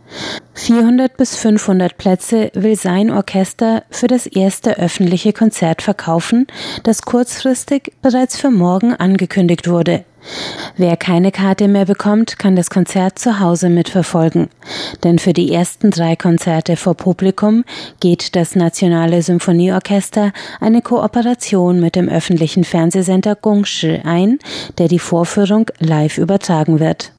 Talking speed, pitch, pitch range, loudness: 125 wpm, 190 Hz, 175-215 Hz, -14 LUFS